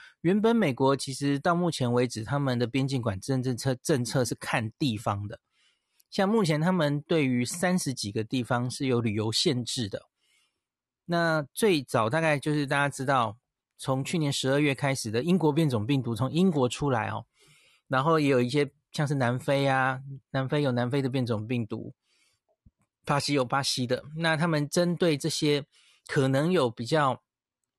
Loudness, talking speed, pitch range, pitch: -27 LUFS, 255 characters per minute, 125-150 Hz, 135 Hz